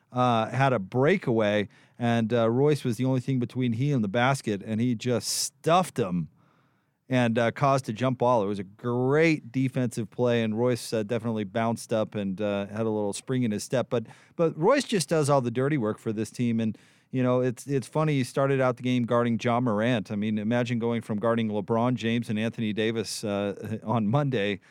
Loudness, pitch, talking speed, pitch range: -26 LUFS, 120 Hz, 215 wpm, 110-130 Hz